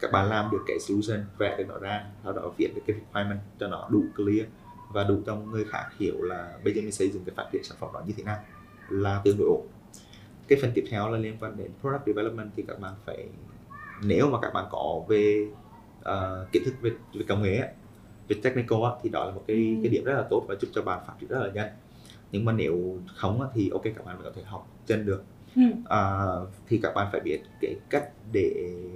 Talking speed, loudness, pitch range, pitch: 240 wpm, -29 LUFS, 100-110 Hz, 105 Hz